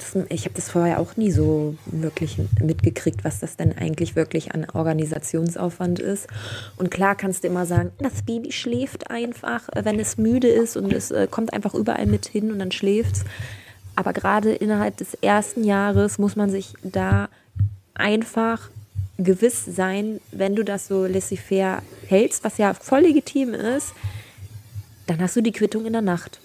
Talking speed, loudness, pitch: 170 wpm, -23 LUFS, 190 Hz